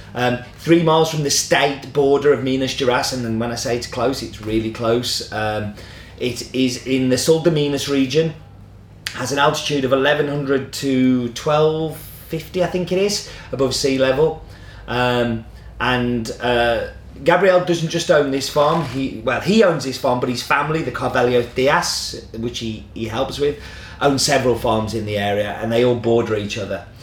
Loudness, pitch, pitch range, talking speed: -19 LUFS, 125 Hz, 115-145 Hz, 180 wpm